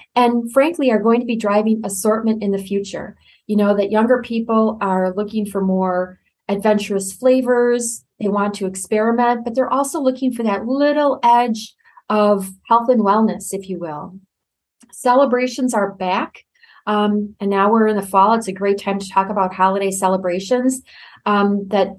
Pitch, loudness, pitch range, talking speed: 210 Hz, -18 LUFS, 195-240 Hz, 170 wpm